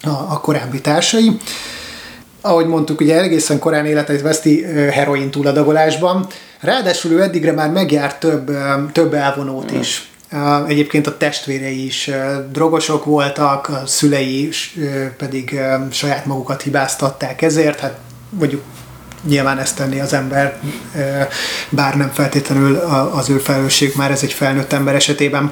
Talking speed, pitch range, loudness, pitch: 125 wpm, 135-155 Hz, -15 LUFS, 145 Hz